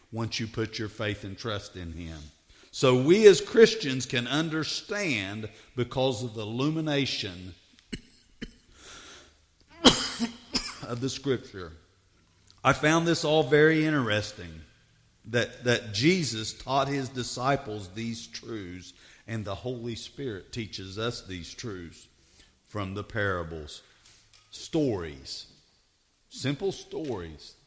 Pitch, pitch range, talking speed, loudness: 115 Hz, 100-140 Hz, 110 wpm, -27 LUFS